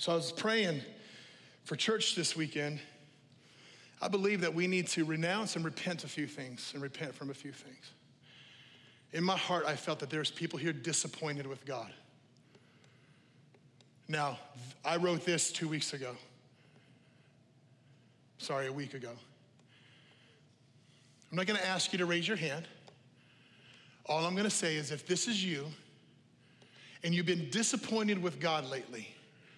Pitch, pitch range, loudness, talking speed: 150 Hz, 135-170 Hz, -35 LUFS, 150 wpm